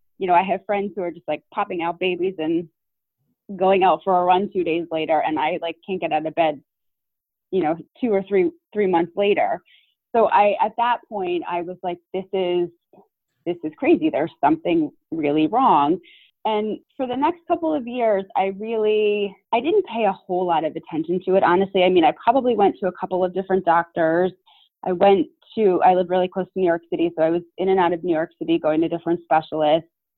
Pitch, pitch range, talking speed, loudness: 185 Hz, 170-215 Hz, 220 wpm, -21 LUFS